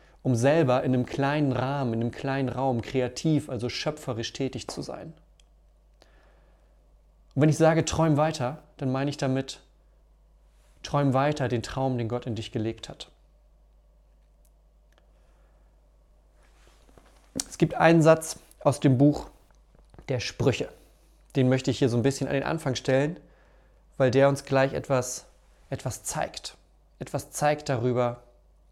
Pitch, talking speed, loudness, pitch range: 135 Hz, 140 wpm, -26 LUFS, 125-145 Hz